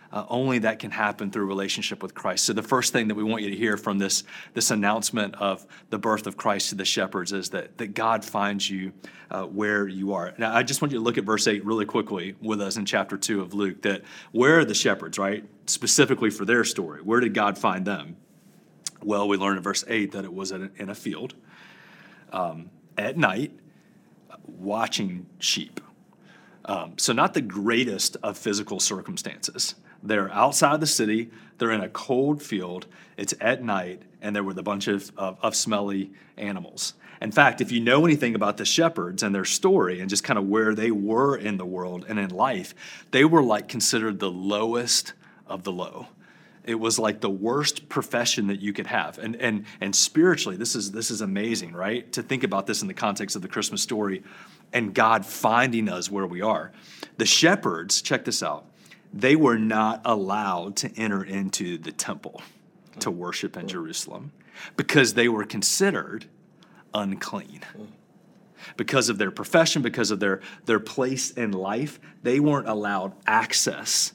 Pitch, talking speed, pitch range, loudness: 105 Hz, 190 wpm, 100-115 Hz, -24 LUFS